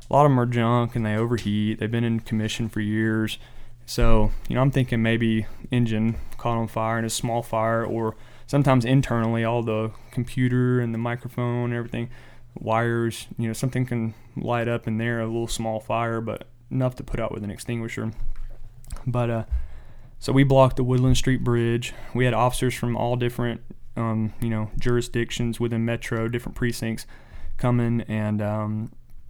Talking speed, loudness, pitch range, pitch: 180 wpm, -25 LUFS, 110-120 Hz, 115 Hz